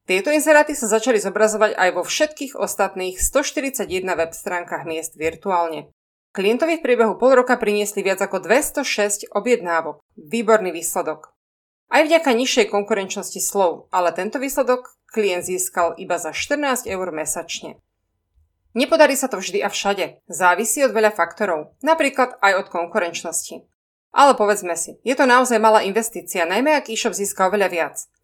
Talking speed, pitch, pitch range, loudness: 145 wpm, 200 Hz, 175-245 Hz, -19 LUFS